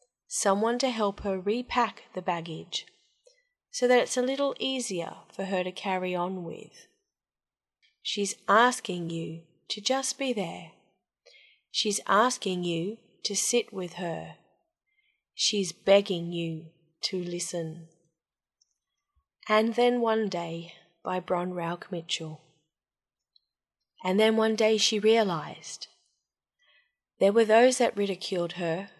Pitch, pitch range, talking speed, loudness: 195 Hz, 175-225 Hz, 120 wpm, -28 LUFS